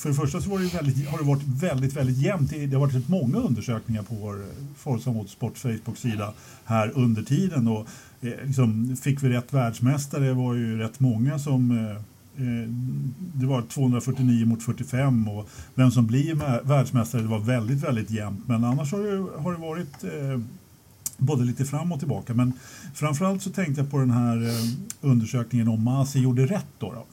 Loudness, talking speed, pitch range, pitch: -25 LUFS, 190 wpm, 115-140 Hz, 130 Hz